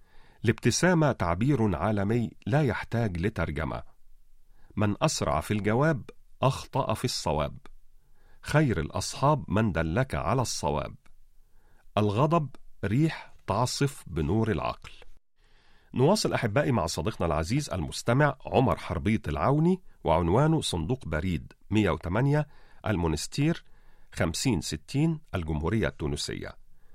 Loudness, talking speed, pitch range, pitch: -28 LUFS, 90 wpm, 85-135 Hz, 110 Hz